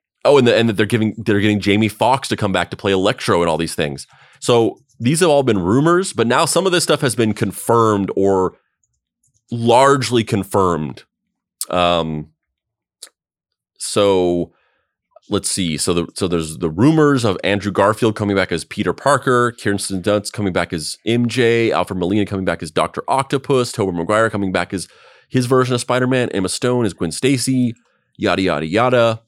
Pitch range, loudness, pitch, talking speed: 95-125 Hz, -17 LUFS, 110 Hz, 175 wpm